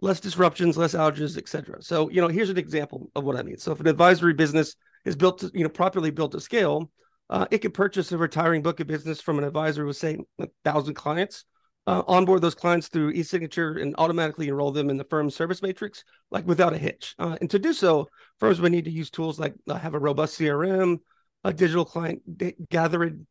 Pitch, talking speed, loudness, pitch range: 165 Hz, 225 wpm, -25 LUFS, 155-185 Hz